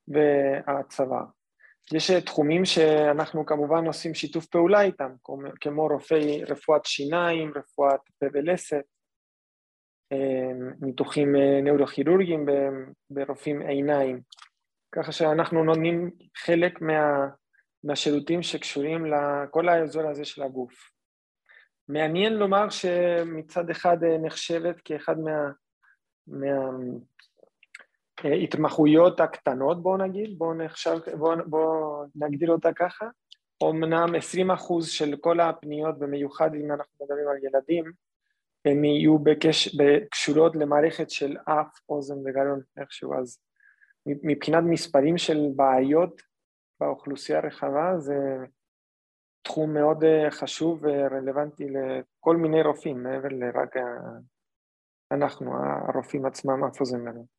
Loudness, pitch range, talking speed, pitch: -25 LUFS, 140-165 Hz, 100 wpm, 150 Hz